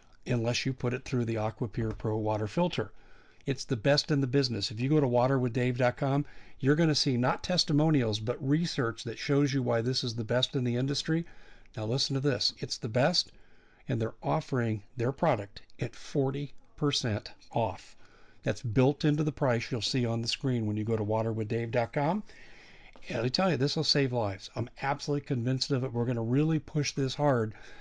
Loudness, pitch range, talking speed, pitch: -30 LUFS, 115-145 Hz, 195 wpm, 130 Hz